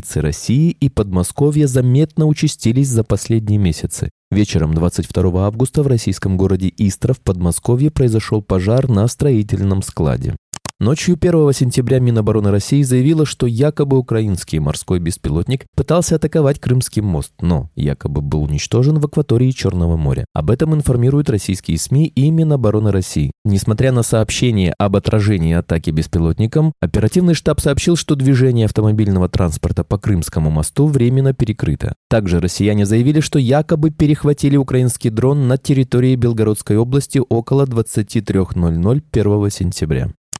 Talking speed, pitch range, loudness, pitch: 130 wpm, 95-140 Hz, -15 LUFS, 115 Hz